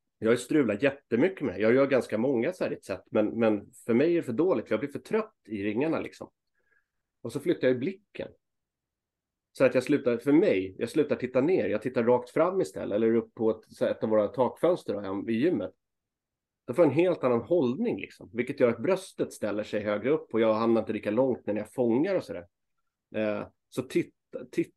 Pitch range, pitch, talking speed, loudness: 105-135 Hz, 115 Hz, 235 wpm, -28 LUFS